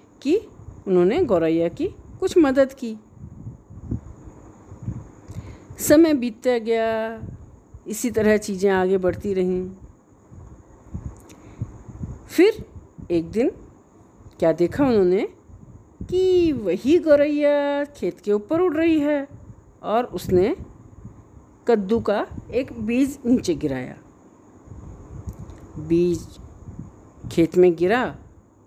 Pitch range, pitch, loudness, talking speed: 180-290 Hz, 225 Hz, -21 LUFS, 90 wpm